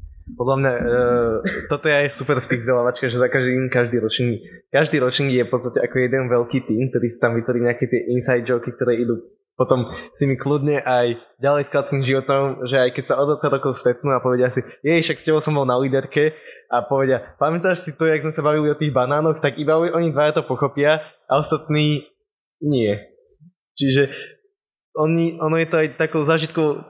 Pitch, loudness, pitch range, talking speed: 140 Hz, -20 LUFS, 125-155 Hz, 200 wpm